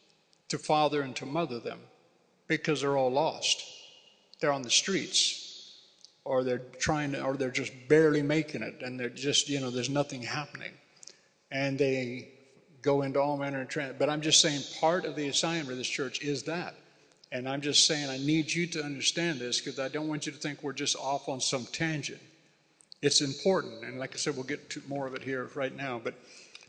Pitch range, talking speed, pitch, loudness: 135-155 Hz, 205 wpm, 145 Hz, -30 LUFS